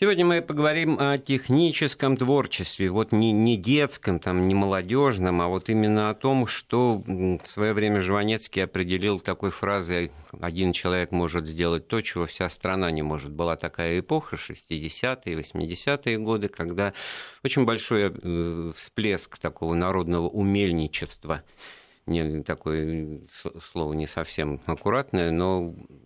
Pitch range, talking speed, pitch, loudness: 85-115 Hz, 125 wpm, 95 Hz, -26 LUFS